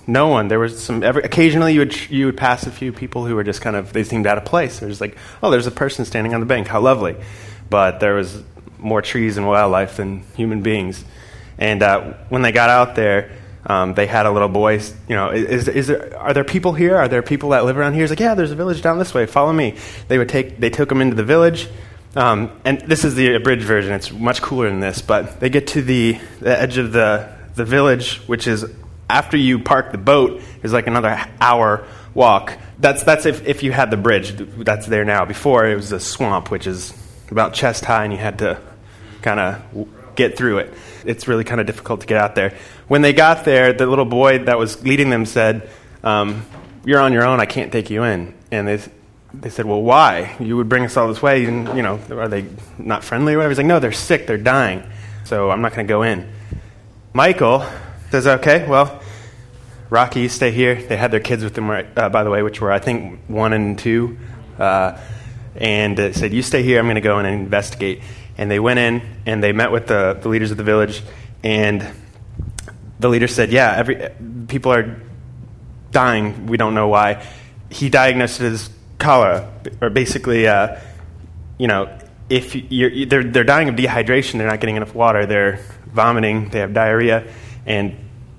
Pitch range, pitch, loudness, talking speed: 105-125 Hz, 115 Hz, -16 LUFS, 220 wpm